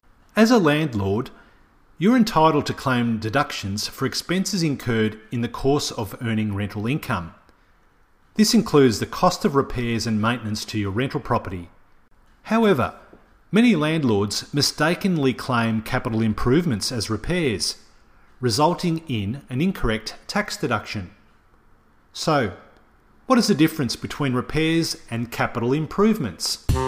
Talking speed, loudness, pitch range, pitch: 125 wpm, -22 LUFS, 110-160 Hz, 125 Hz